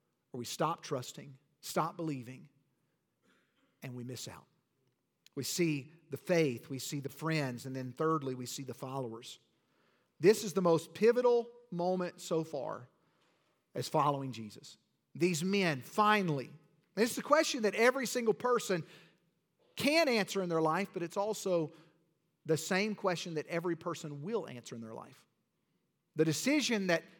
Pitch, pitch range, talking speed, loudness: 165 Hz, 145-195 Hz, 150 wpm, -33 LUFS